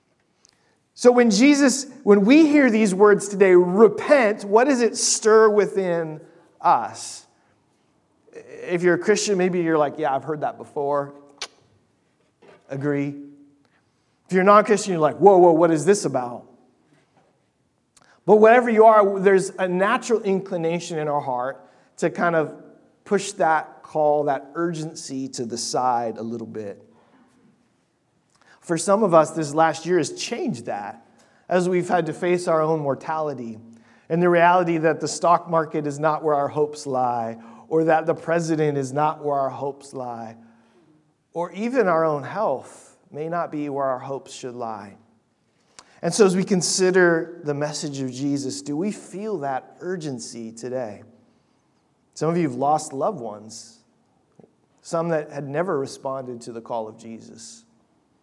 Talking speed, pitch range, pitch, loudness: 155 wpm, 140-190 Hz, 160 Hz, -20 LUFS